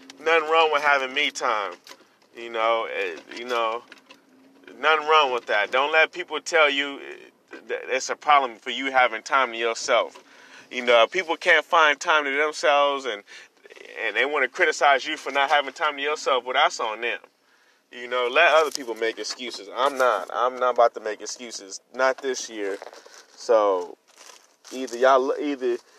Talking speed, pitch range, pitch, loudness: 175 wpm, 125-195 Hz, 145 Hz, -22 LUFS